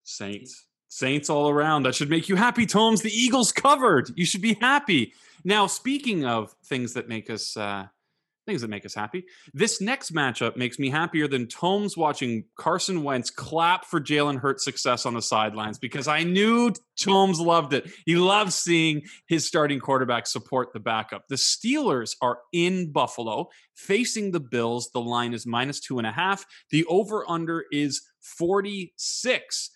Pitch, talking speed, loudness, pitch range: 150 Hz, 170 wpm, -24 LUFS, 125-195 Hz